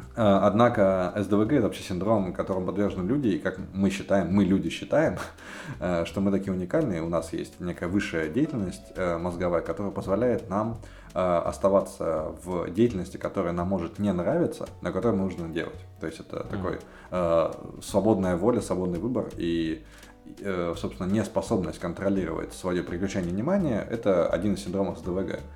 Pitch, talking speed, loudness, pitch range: 95 Hz, 145 wpm, -27 LUFS, 90-100 Hz